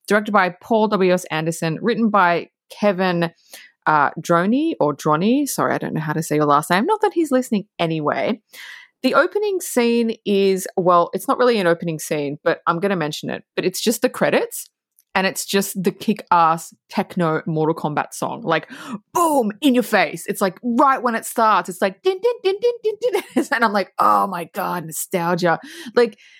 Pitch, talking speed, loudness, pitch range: 200 Hz, 195 wpm, -19 LUFS, 170-245 Hz